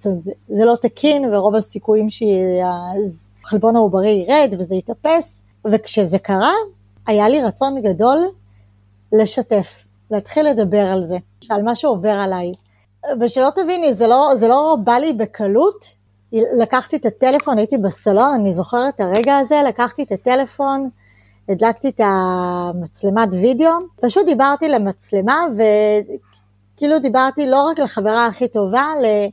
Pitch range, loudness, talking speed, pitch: 195-270 Hz, -16 LUFS, 130 wpm, 220 Hz